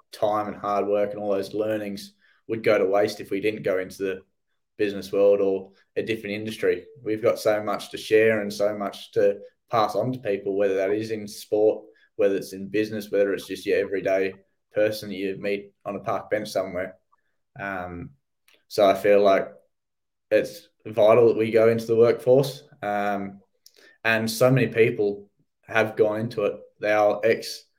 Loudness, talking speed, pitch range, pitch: -24 LUFS, 185 wpm, 100-115 Hz, 105 Hz